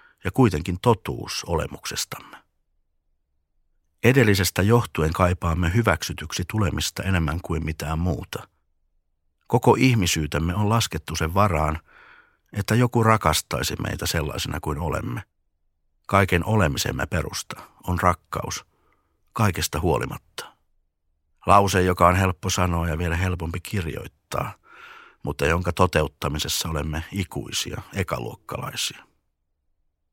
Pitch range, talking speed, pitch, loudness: 75-95 Hz, 95 wpm, 85 Hz, -23 LUFS